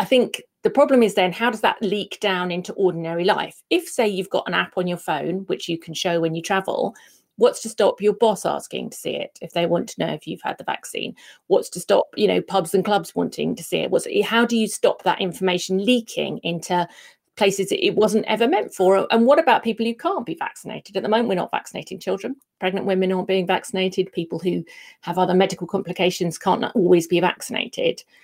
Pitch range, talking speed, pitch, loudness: 180-230 Hz, 225 wpm, 195 Hz, -21 LUFS